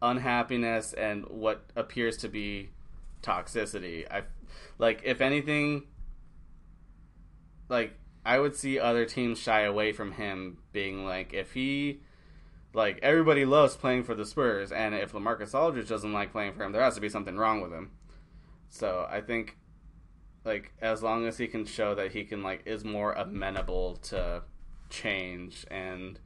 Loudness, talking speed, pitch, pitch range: -30 LUFS, 160 wpm, 110 Hz, 95-120 Hz